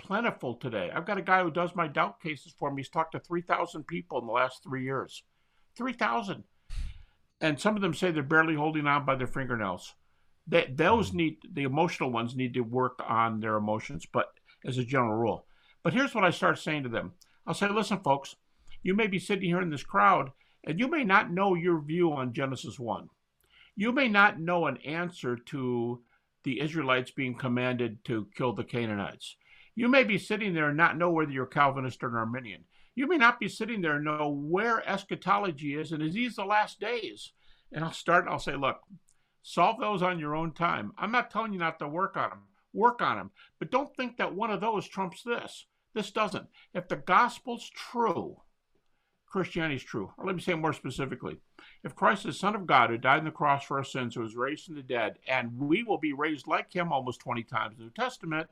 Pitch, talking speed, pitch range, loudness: 155 Hz, 220 wpm, 130-190 Hz, -29 LUFS